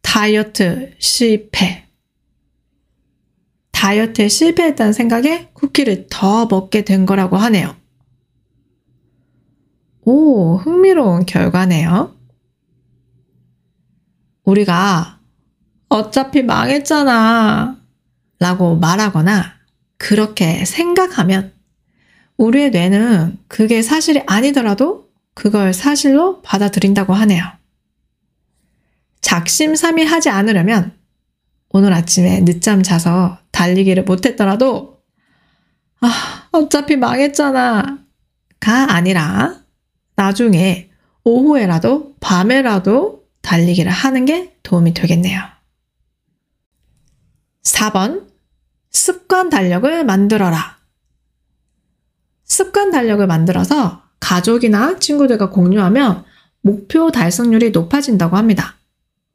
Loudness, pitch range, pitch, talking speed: -13 LUFS, 175-260 Hz, 200 Hz, 205 characters per minute